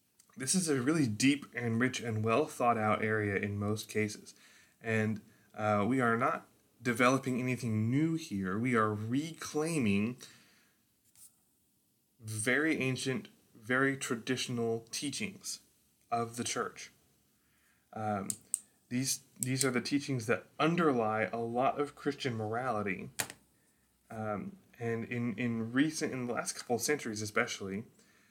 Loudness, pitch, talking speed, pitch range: -33 LUFS, 120 Hz, 125 wpm, 110-135 Hz